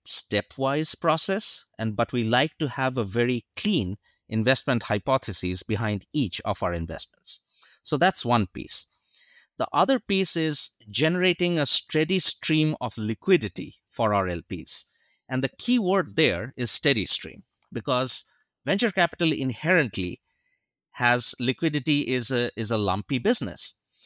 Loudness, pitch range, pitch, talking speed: -24 LUFS, 110-160 Hz, 130 Hz, 135 wpm